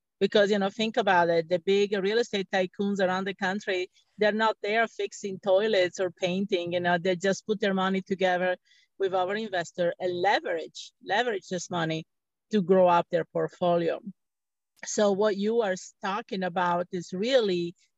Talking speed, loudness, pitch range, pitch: 165 wpm, -27 LUFS, 180-205 Hz, 190 Hz